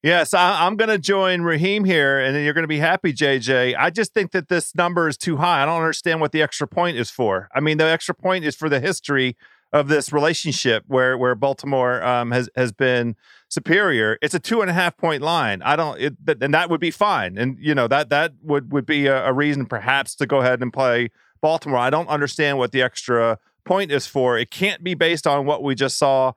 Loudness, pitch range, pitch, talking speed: -20 LUFS, 130-165 Hz, 145 Hz, 245 wpm